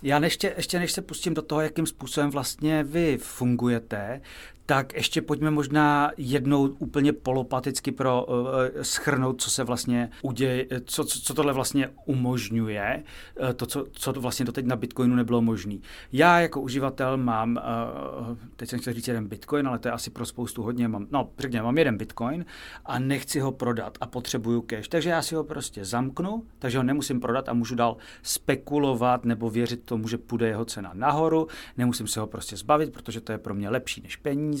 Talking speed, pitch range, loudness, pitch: 190 wpm, 120-145 Hz, -27 LUFS, 130 Hz